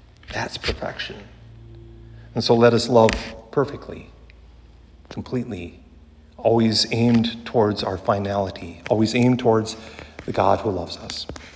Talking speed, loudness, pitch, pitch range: 115 wpm, -21 LUFS, 110 Hz, 85-115 Hz